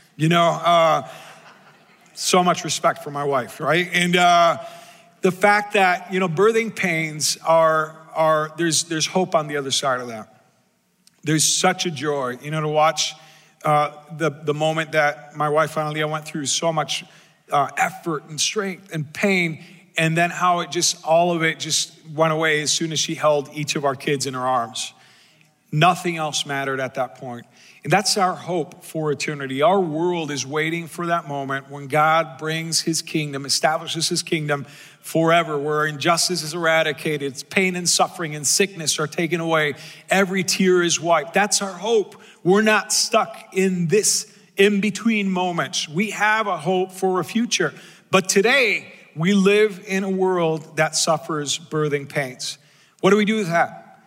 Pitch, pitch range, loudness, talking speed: 165 Hz, 155-185 Hz, -20 LUFS, 175 wpm